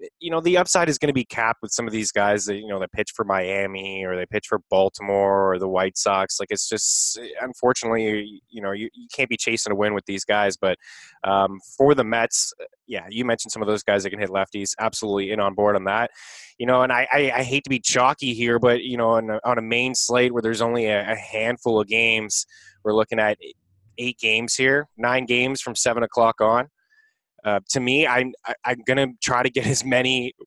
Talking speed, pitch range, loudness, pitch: 235 wpm, 105-125 Hz, -22 LUFS, 115 Hz